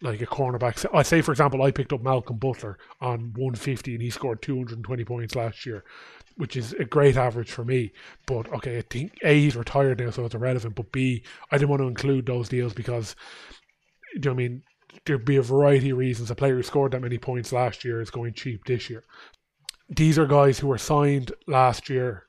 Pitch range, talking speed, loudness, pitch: 120-140 Hz, 225 wpm, -25 LUFS, 130 Hz